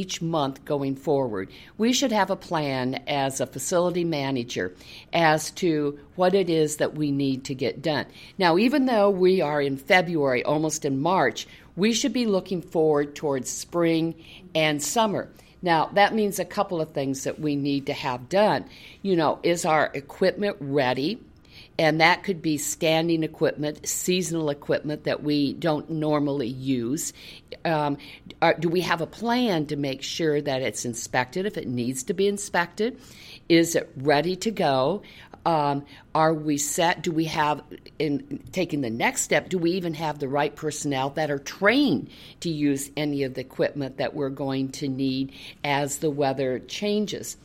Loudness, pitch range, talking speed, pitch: -25 LUFS, 140-180 Hz, 170 wpm, 155 Hz